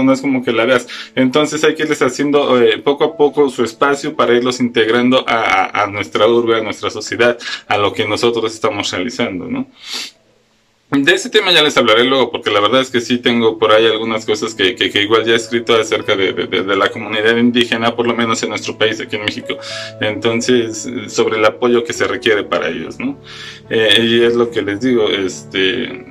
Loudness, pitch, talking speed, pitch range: -14 LUFS, 120 Hz, 220 wpm, 110-130 Hz